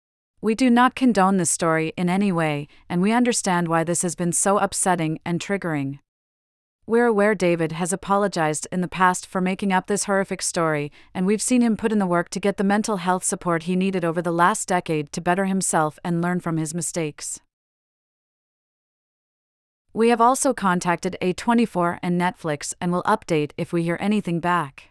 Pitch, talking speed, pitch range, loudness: 180 Hz, 185 wpm, 165-200 Hz, -22 LUFS